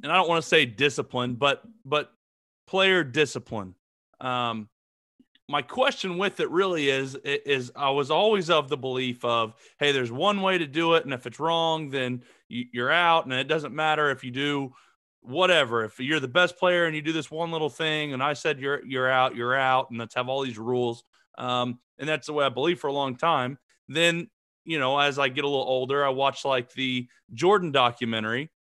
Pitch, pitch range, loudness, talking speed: 140 Hz, 125-160 Hz, -25 LUFS, 210 wpm